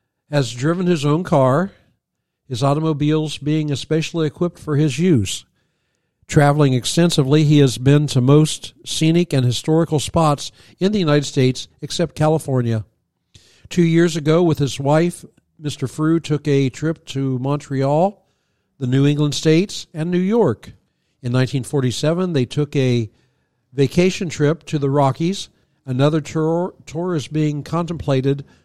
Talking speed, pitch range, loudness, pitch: 140 wpm, 135-160 Hz, -18 LUFS, 150 Hz